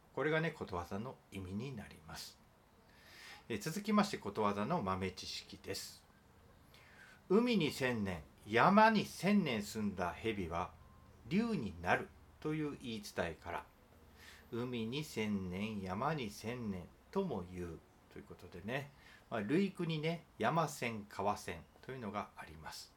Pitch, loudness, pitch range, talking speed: 110 Hz, -38 LUFS, 95-160 Hz, 245 characters per minute